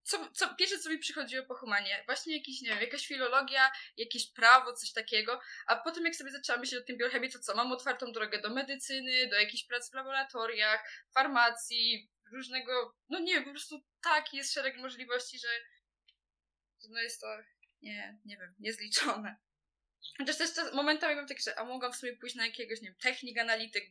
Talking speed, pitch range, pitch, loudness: 185 wpm, 230-275 Hz, 250 Hz, -32 LUFS